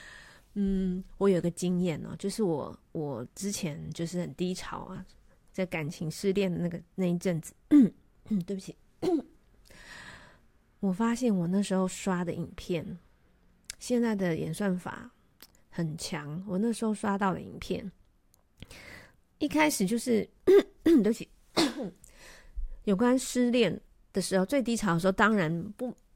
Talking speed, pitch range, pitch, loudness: 200 characters per minute, 175-225 Hz, 195 Hz, -30 LUFS